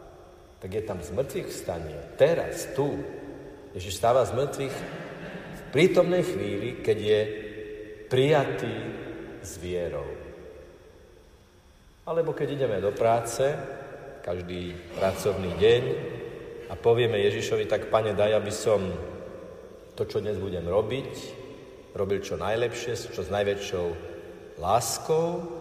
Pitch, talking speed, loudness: 175 Hz, 110 wpm, -27 LUFS